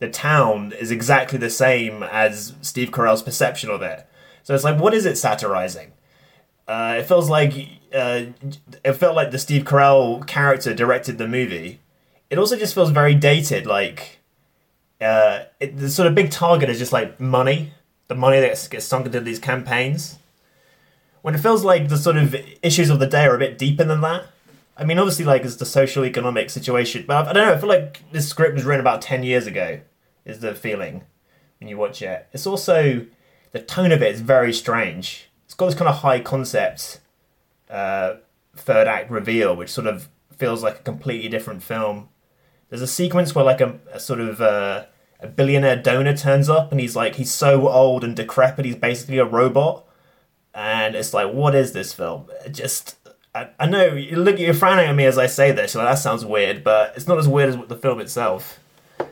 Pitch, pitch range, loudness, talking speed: 135 Hz, 120-150 Hz, -19 LUFS, 205 wpm